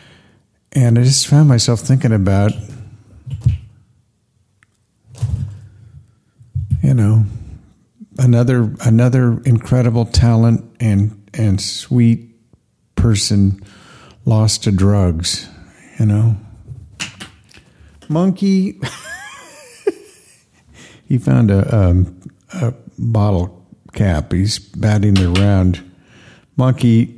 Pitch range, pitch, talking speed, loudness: 100-120 Hz, 110 Hz, 75 wpm, -15 LUFS